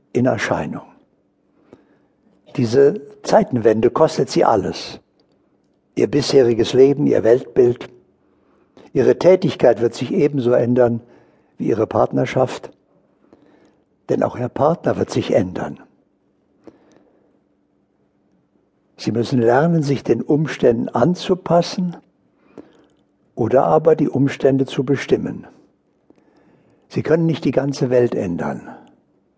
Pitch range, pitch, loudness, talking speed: 120-155 Hz, 135 Hz, -17 LUFS, 100 wpm